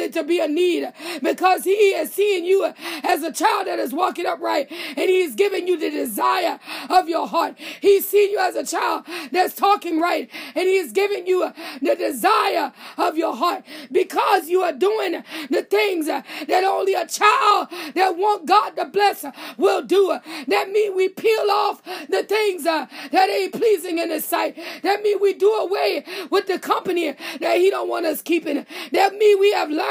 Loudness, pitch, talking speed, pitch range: -20 LUFS, 365 Hz, 190 wpm, 330-395 Hz